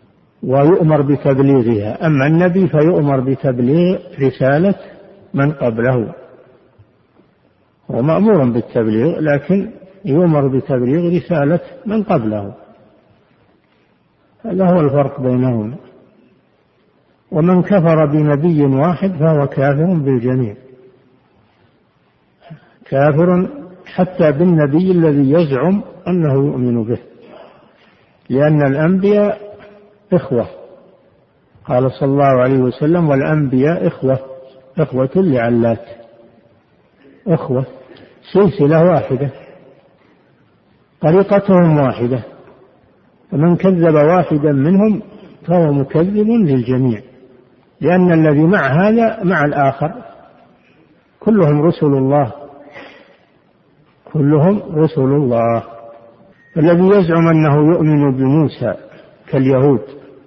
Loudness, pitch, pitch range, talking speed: -14 LUFS, 150 Hz, 130-175 Hz, 80 wpm